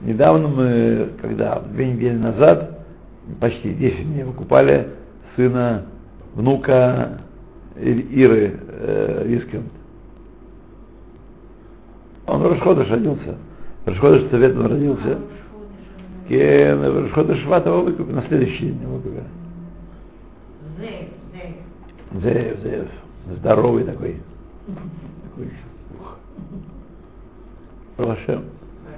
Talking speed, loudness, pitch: 65 wpm, -18 LUFS, 120 Hz